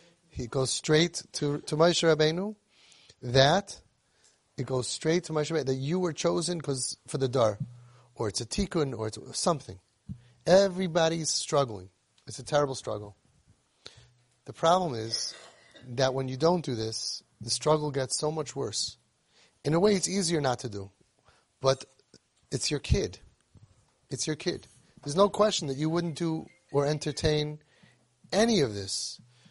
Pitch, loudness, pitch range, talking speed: 145 Hz, -28 LUFS, 125-170 Hz, 155 wpm